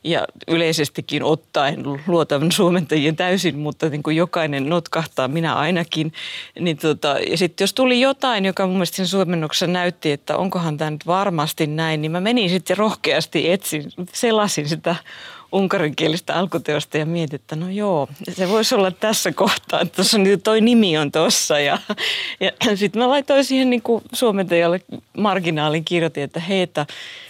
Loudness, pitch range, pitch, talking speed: -19 LUFS, 155-195 Hz, 175 Hz, 155 wpm